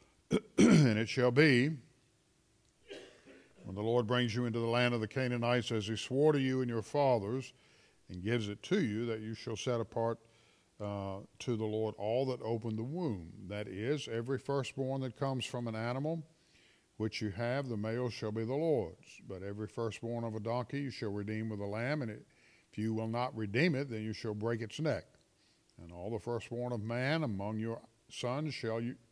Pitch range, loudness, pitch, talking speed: 110-130 Hz, -35 LUFS, 115 Hz, 200 wpm